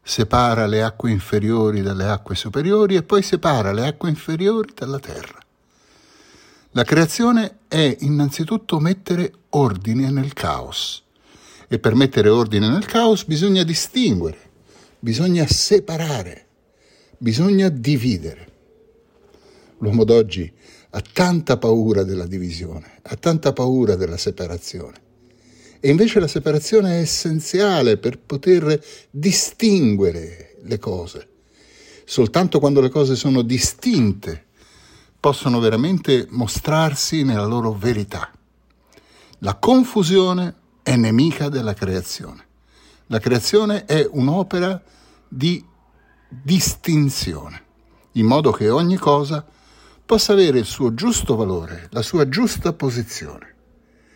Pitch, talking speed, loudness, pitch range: 140 Hz, 105 wpm, -18 LUFS, 110-175 Hz